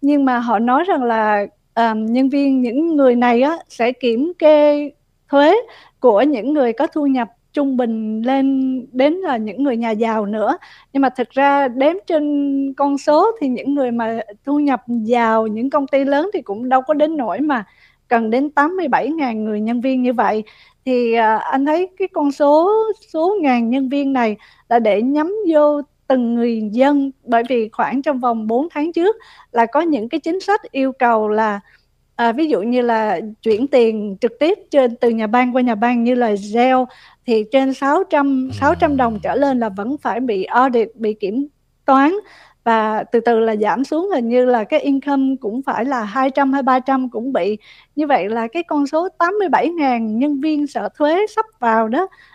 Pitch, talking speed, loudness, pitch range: 265 Hz, 195 wpm, -17 LUFS, 235-295 Hz